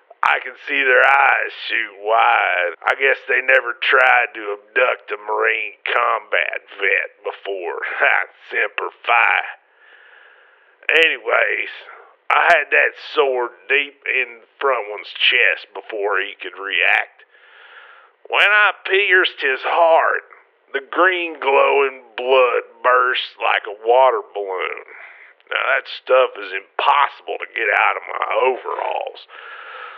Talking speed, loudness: 120 wpm, -17 LUFS